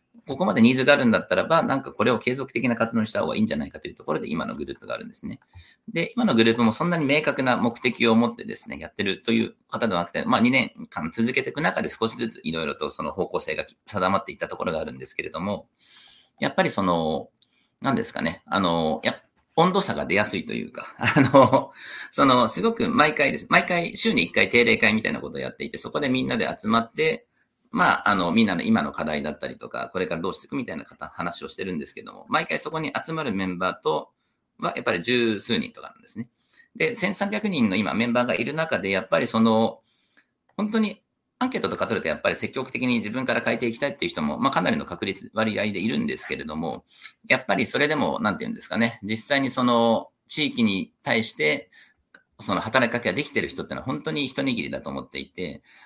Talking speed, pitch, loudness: 450 characters per minute, 135 Hz, -23 LUFS